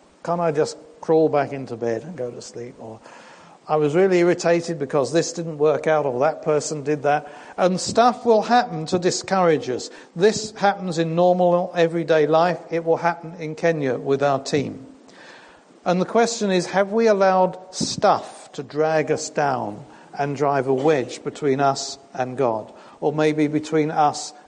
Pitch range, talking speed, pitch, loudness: 145-180 Hz, 175 wpm, 160 Hz, -21 LUFS